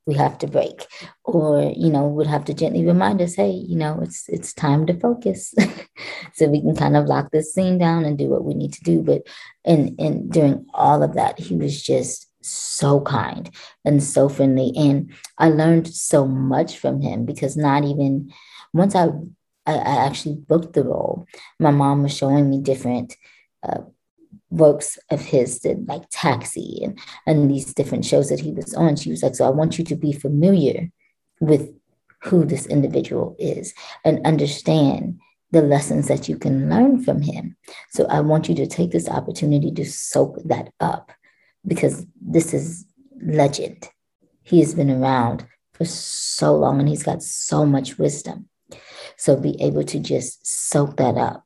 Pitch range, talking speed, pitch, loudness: 140-165 Hz, 180 wpm, 150 Hz, -20 LUFS